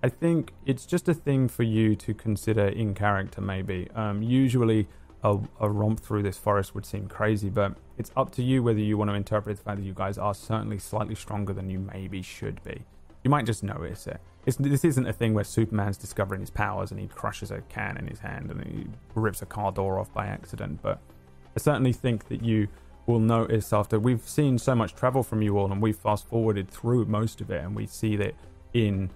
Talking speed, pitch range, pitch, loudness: 225 wpm, 100-115 Hz, 105 Hz, -28 LUFS